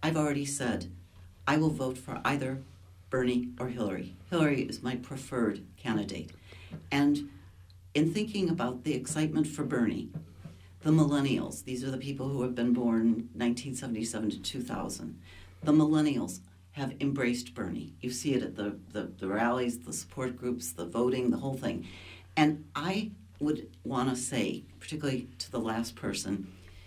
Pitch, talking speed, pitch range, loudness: 125 Hz, 155 wpm, 95-135 Hz, -32 LUFS